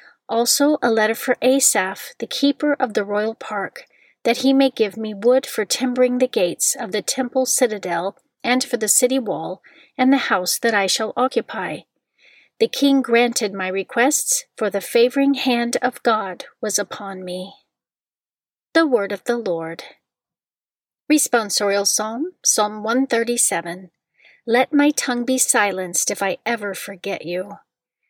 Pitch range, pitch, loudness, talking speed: 205-265 Hz, 235 Hz, -19 LUFS, 150 wpm